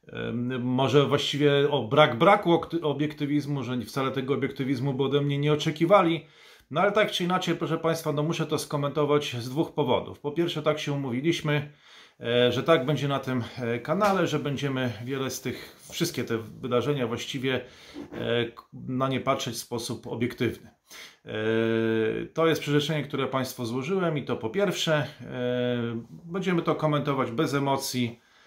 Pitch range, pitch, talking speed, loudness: 125-155 Hz, 140 Hz, 150 wpm, -27 LUFS